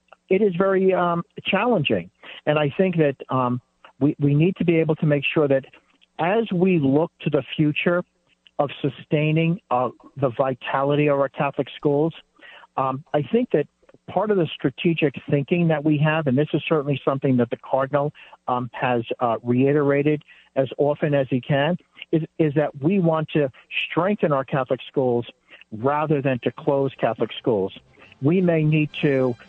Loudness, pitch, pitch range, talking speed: -22 LUFS, 150 Hz, 135-165 Hz, 170 wpm